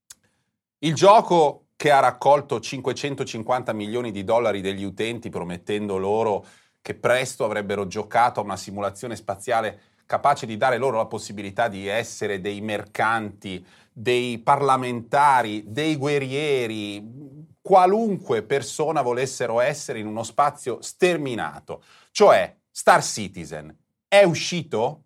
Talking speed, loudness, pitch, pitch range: 115 wpm, -22 LUFS, 115 Hz, 105-140 Hz